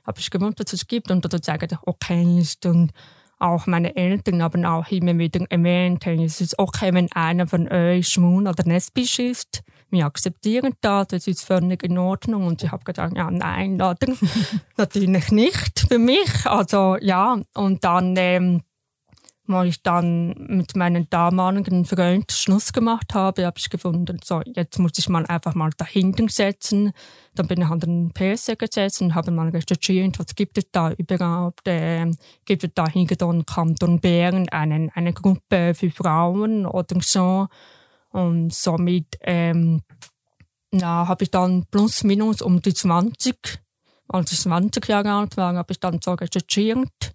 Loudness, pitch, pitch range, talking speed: -21 LUFS, 180 Hz, 170-195 Hz, 165 wpm